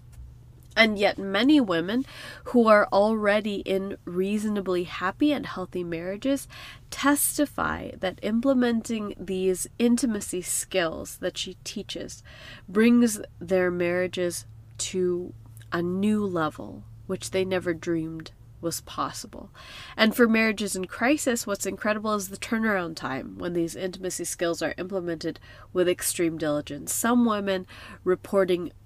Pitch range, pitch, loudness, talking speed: 170-215 Hz, 185 Hz, -26 LUFS, 120 wpm